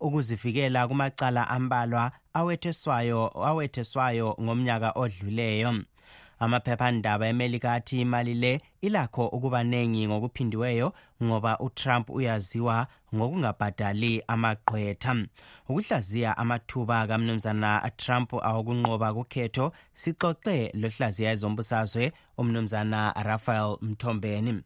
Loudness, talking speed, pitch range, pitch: -28 LUFS, 80 wpm, 110-125 Hz, 120 Hz